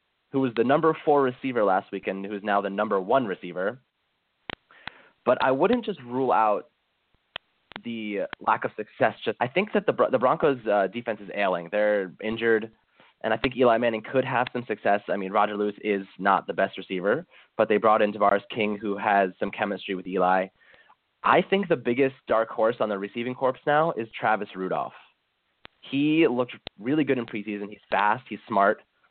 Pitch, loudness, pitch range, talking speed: 110 Hz, -25 LUFS, 100-125 Hz, 185 wpm